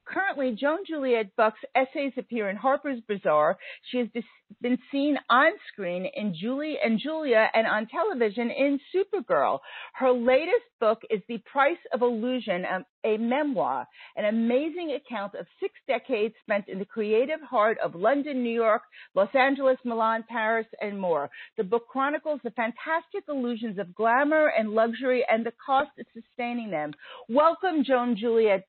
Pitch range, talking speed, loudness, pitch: 220-280 Hz, 155 wpm, -26 LUFS, 245 Hz